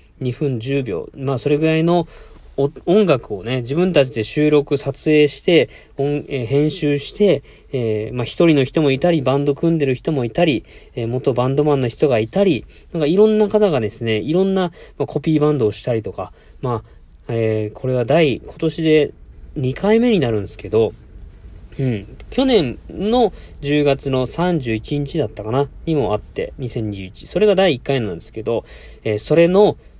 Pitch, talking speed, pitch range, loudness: 140 Hz, 280 characters per minute, 120-160 Hz, -18 LUFS